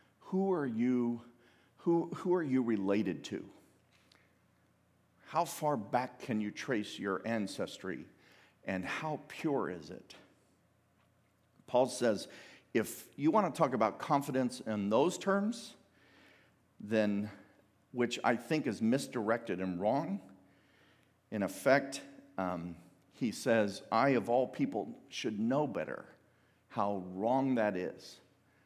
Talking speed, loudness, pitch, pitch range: 120 wpm, -34 LUFS, 120 Hz, 100-140 Hz